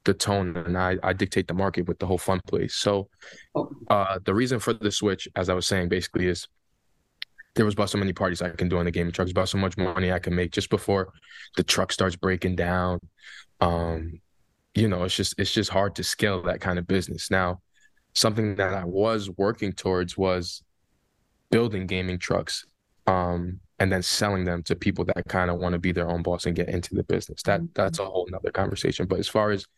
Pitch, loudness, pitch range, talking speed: 95 Hz, -26 LUFS, 90-100 Hz, 220 wpm